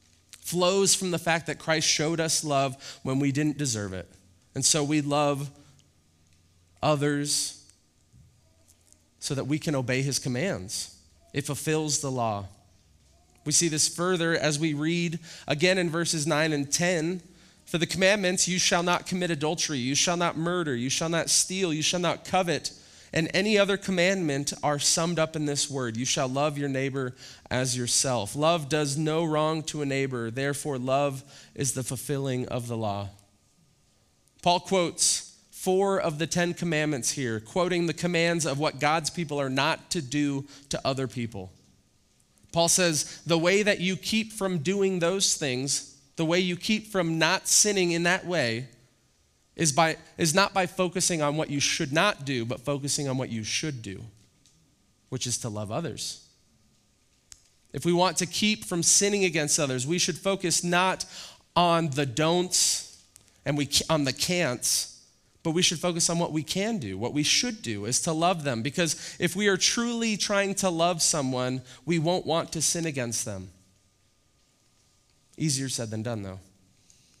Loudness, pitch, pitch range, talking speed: -26 LUFS, 150 Hz, 125-175 Hz, 170 wpm